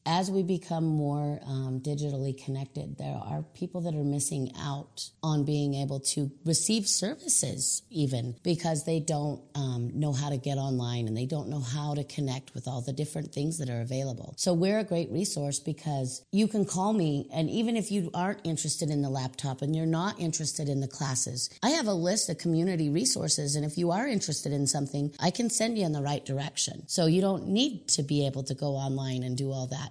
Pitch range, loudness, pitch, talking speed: 135-170 Hz, -30 LUFS, 150 Hz, 215 wpm